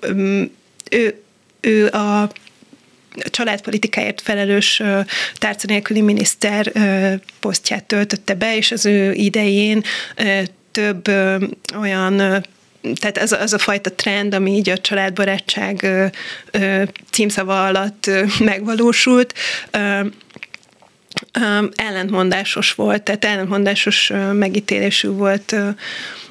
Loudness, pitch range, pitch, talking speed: -17 LUFS, 195-210 Hz, 205 Hz, 85 wpm